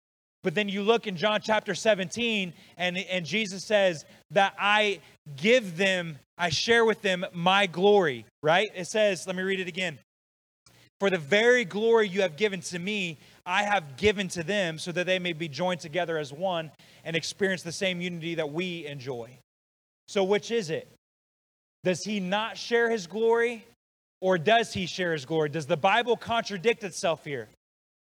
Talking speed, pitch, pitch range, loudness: 175 wpm, 185 Hz, 165-205 Hz, -27 LUFS